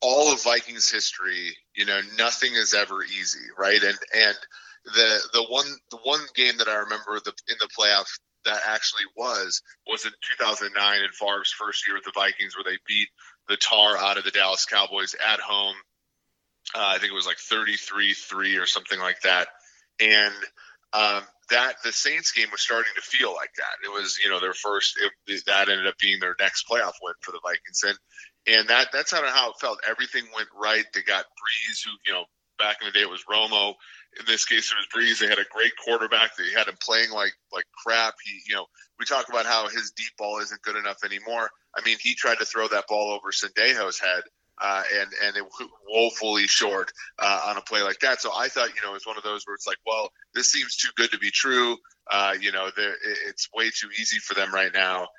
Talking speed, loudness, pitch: 220 wpm, -23 LUFS, 110 Hz